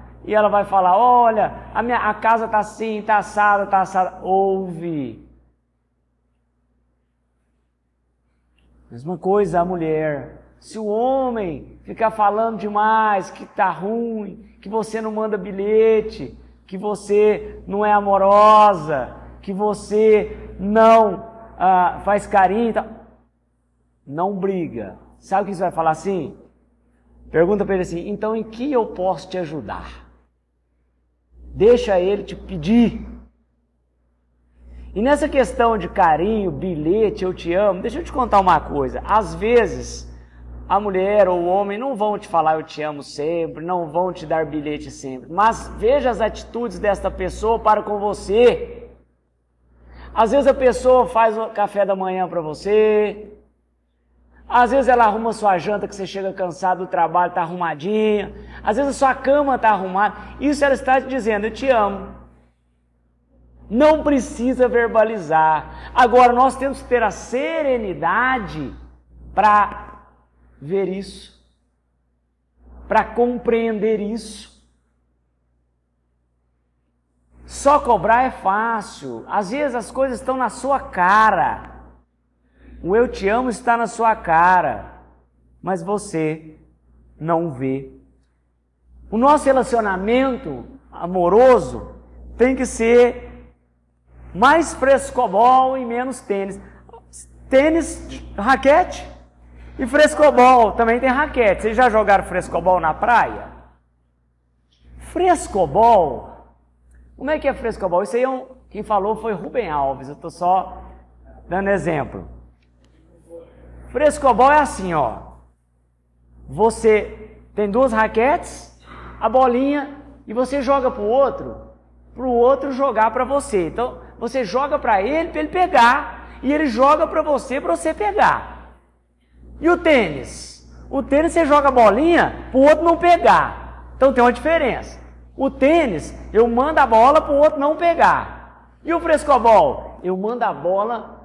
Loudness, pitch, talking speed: -18 LUFS, 200 Hz, 135 wpm